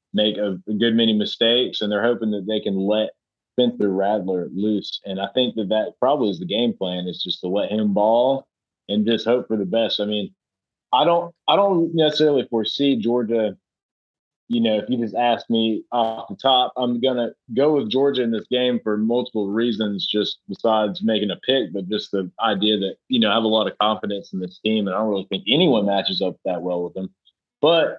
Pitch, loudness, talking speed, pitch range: 110 Hz, -21 LUFS, 215 wpm, 100-120 Hz